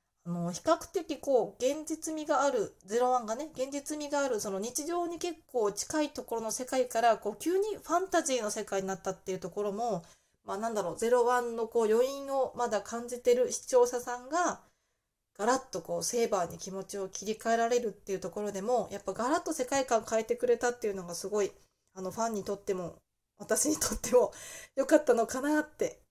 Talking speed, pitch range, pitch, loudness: 400 characters per minute, 205-285 Hz, 240 Hz, -31 LUFS